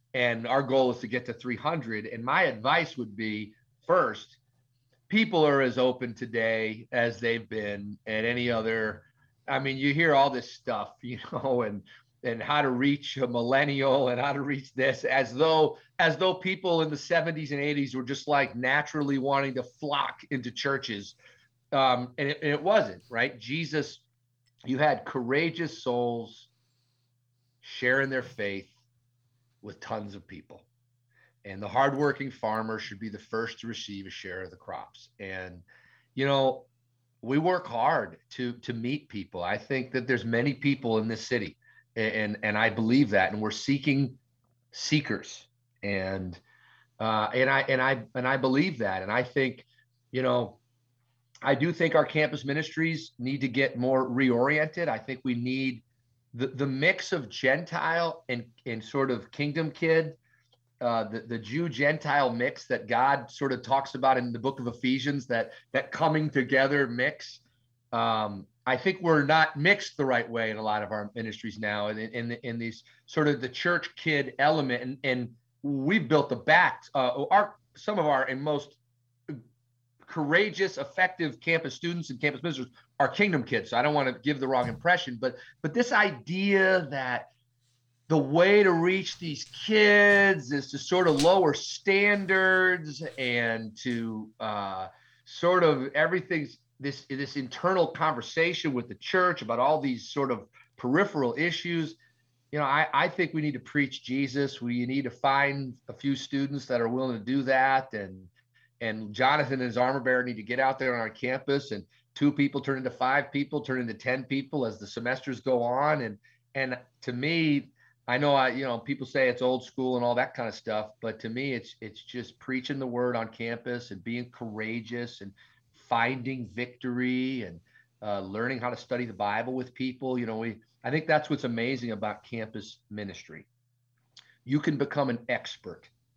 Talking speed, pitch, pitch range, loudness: 180 wpm, 125 Hz, 120-145 Hz, -28 LUFS